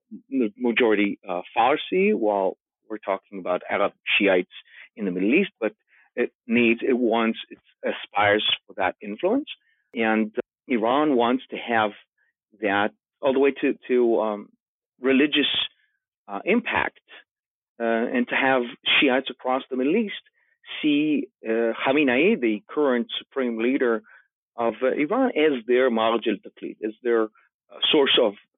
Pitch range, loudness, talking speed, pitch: 110-135 Hz, -23 LUFS, 145 wpm, 120 Hz